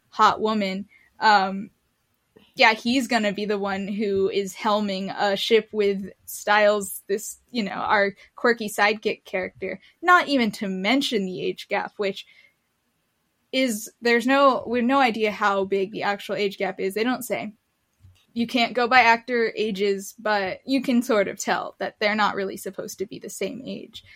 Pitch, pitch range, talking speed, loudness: 210 Hz, 200-235 Hz, 175 wpm, -23 LUFS